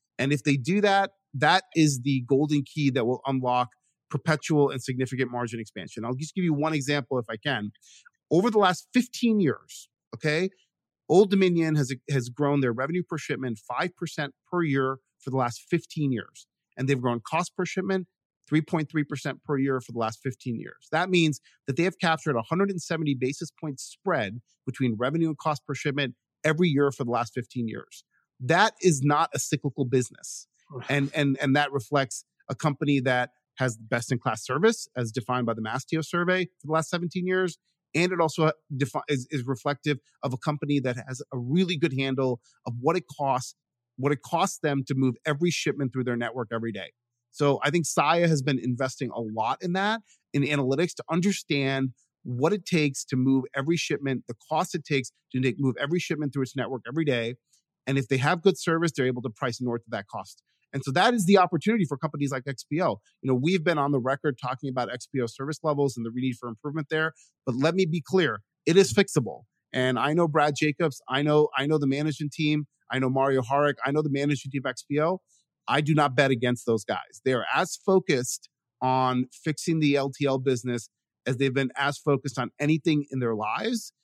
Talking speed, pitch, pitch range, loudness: 200 wpm, 140 Hz, 130-160 Hz, -27 LUFS